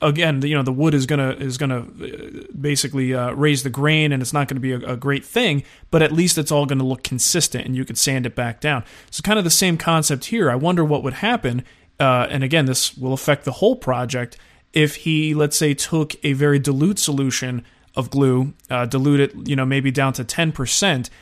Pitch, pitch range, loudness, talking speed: 140 Hz, 130-150 Hz, -19 LUFS, 230 wpm